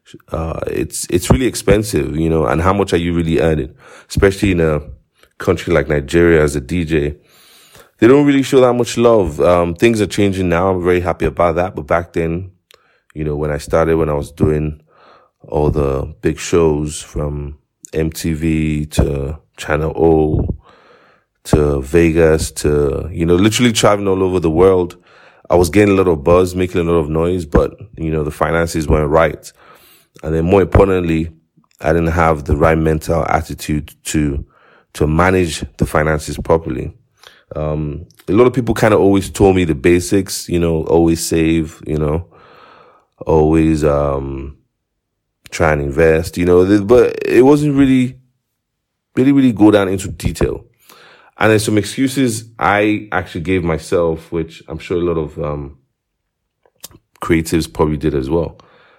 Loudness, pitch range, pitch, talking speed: -15 LUFS, 75-95 Hz, 85 Hz, 165 wpm